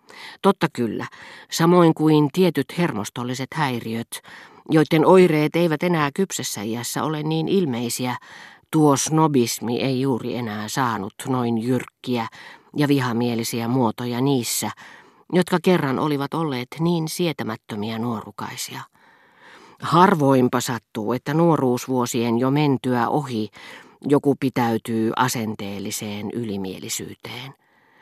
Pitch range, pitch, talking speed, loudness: 115-155 Hz, 130 Hz, 100 wpm, -21 LUFS